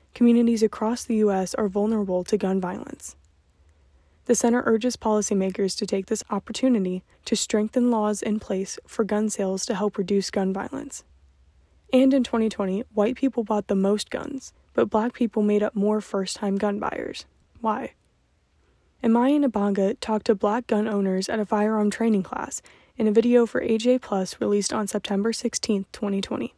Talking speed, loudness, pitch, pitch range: 165 wpm, -24 LUFS, 210 Hz, 195-230 Hz